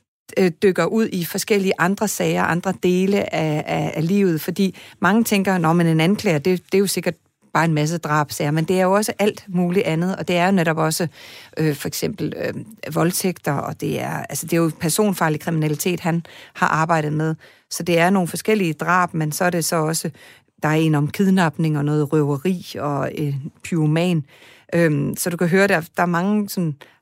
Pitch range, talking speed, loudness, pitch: 155-185 Hz, 205 wpm, -20 LUFS, 170 Hz